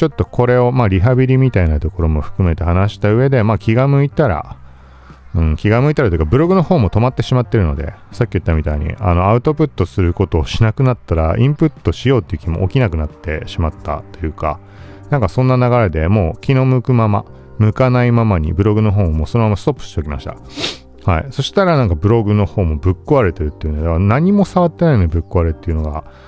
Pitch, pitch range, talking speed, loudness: 100 Hz, 80-125 Hz, 490 characters per minute, -15 LUFS